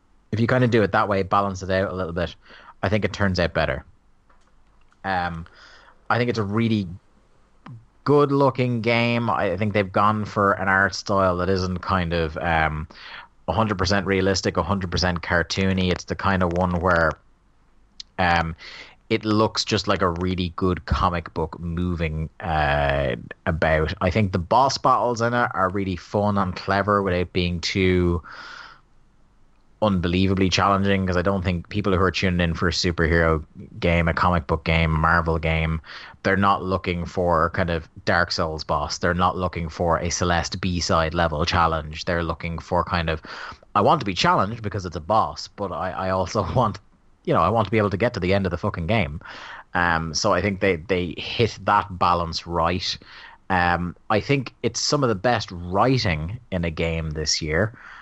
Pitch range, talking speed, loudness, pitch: 85-100 Hz, 185 wpm, -22 LUFS, 95 Hz